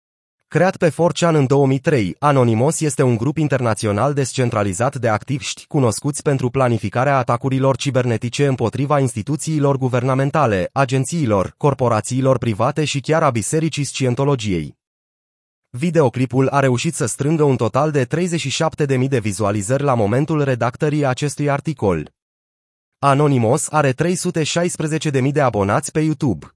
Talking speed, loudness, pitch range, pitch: 120 wpm, -18 LUFS, 120-150 Hz, 135 Hz